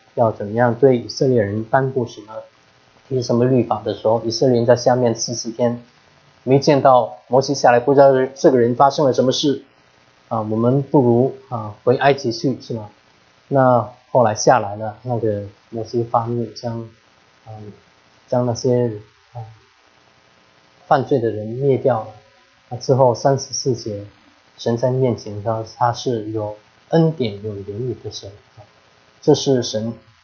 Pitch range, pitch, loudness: 105-125 Hz, 115 Hz, -18 LUFS